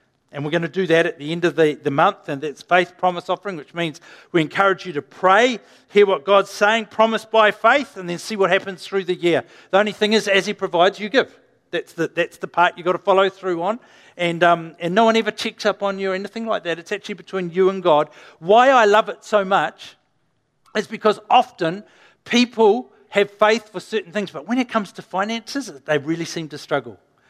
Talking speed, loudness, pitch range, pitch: 235 wpm, -19 LUFS, 170-210 Hz, 190 Hz